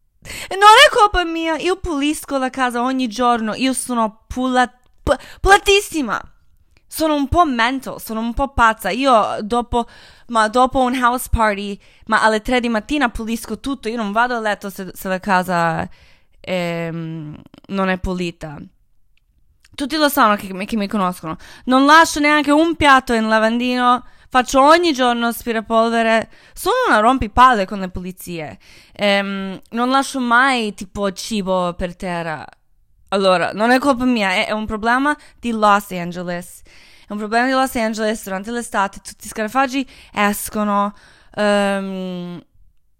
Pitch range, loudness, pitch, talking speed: 200-260 Hz, -17 LUFS, 225 Hz, 150 wpm